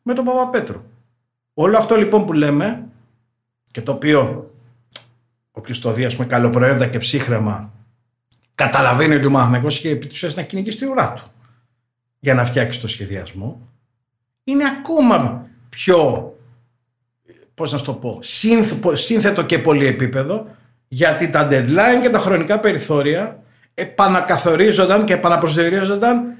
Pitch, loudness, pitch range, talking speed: 135 Hz, -16 LUFS, 120-185 Hz, 120 wpm